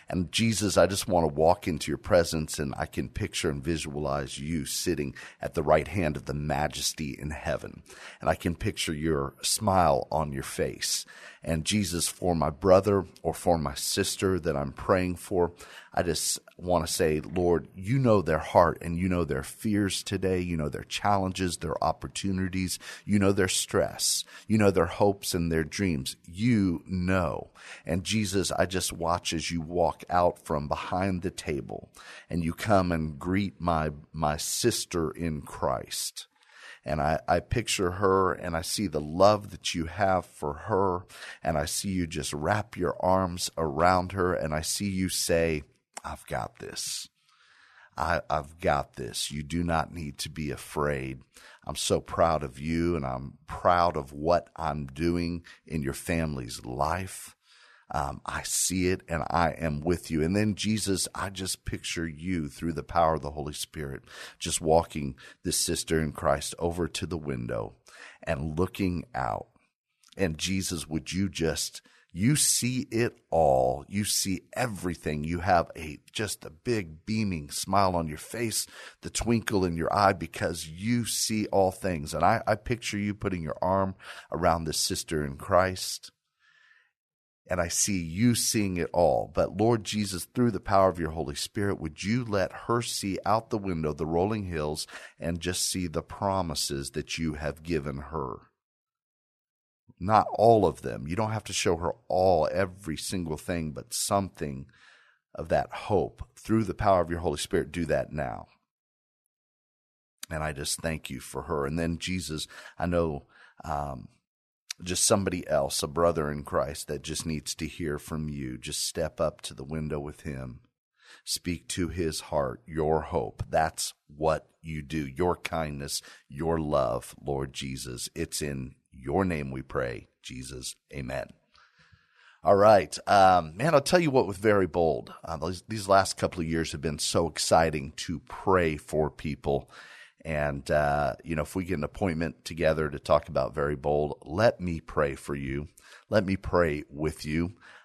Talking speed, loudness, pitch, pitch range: 175 wpm, -28 LUFS, 85 Hz, 75-95 Hz